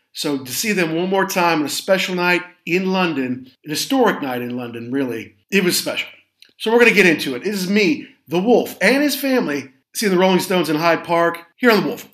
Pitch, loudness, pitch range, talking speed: 180 Hz, -18 LUFS, 145-200 Hz, 235 wpm